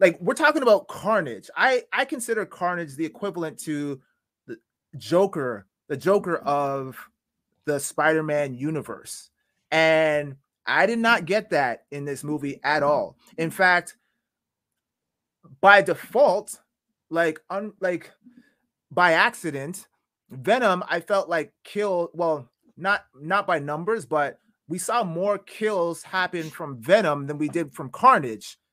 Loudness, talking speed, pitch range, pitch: -23 LUFS, 130 wpm, 150-200 Hz, 170 Hz